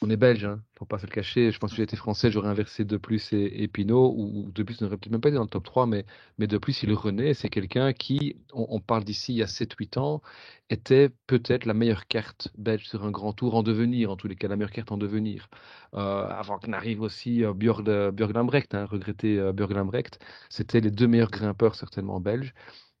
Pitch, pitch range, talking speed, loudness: 110 Hz, 105-115 Hz, 250 wpm, -27 LUFS